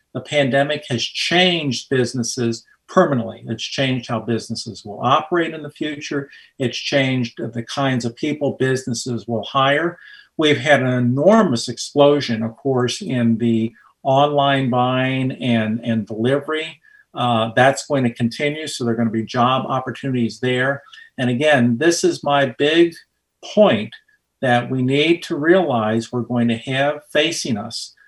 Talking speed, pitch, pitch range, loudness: 150 wpm, 130 Hz, 120-145 Hz, -19 LUFS